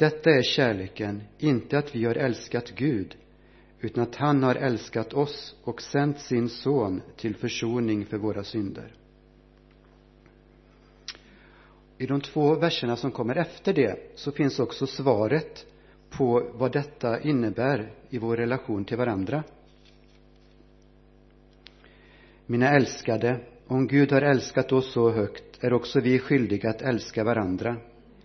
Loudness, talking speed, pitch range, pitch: -26 LUFS, 130 wpm, 105-140 Hz, 120 Hz